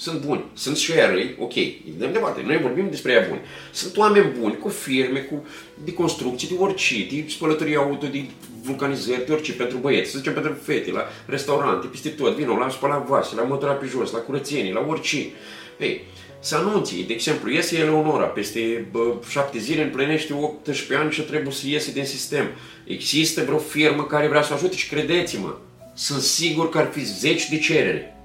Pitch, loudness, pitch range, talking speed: 150 Hz, -22 LUFS, 135-155 Hz, 185 wpm